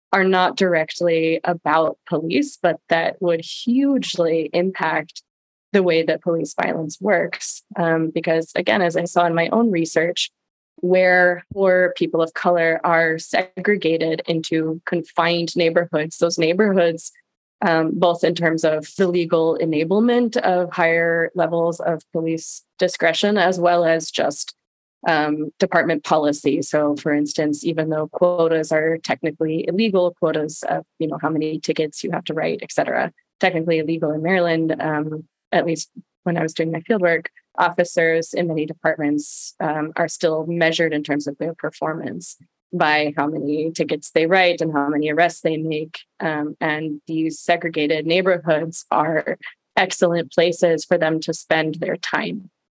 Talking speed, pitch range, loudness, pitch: 150 wpm, 160-175 Hz, -20 LUFS, 165 Hz